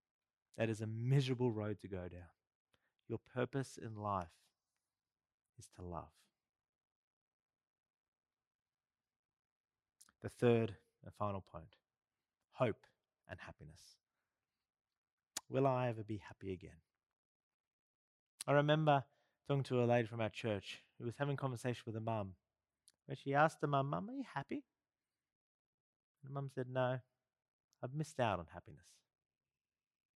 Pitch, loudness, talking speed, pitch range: 115 Hz, -40 LUFS, 130 wpm, 100-135 Hz